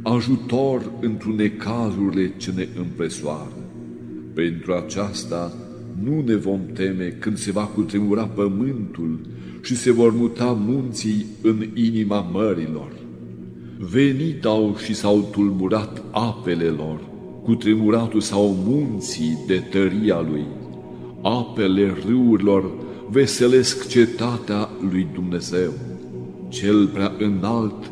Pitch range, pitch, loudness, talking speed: 85-110 Hz, 100 Hz, -21 LUFS, 105 wpm